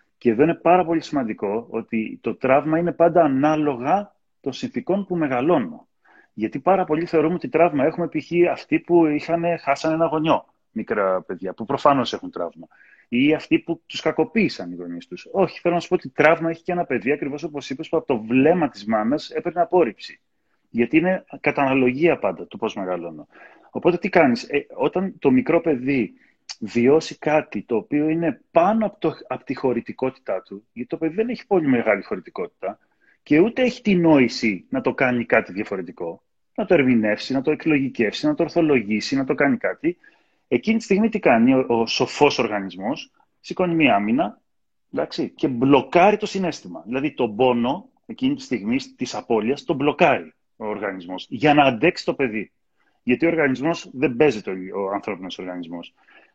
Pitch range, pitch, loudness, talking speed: 125-175 Hz, 155 Hz, -21 LUFS, 175 wpm